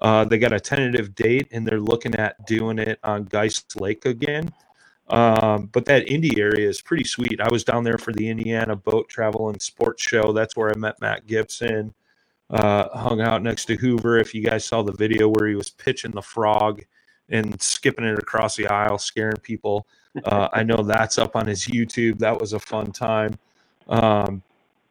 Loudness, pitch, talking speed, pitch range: -22 LUFS, 110 Hz, 200 wpm, 105-115 Hz